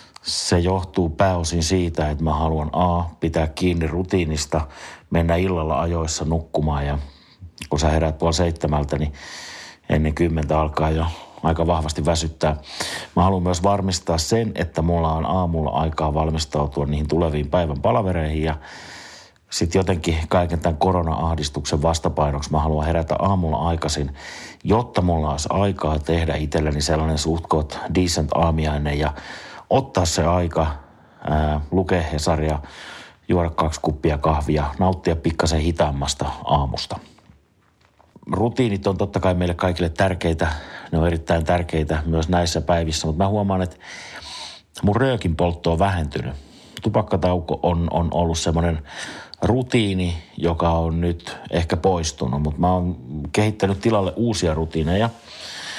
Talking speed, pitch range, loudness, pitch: 130 wpm, 80-90 Hz, -21 LUFS, 85 Hz